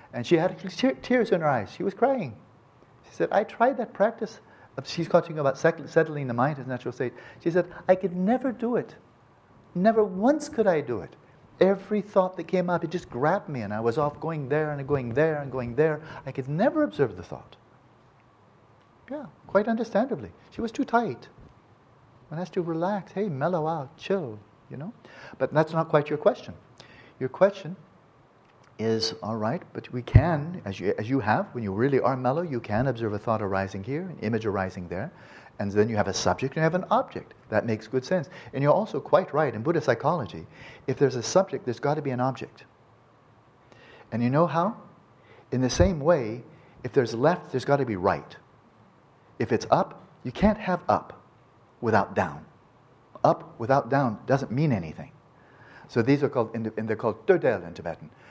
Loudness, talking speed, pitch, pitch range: -26 LUFS, 195 wpm, 145 Hz, 120-180 Hz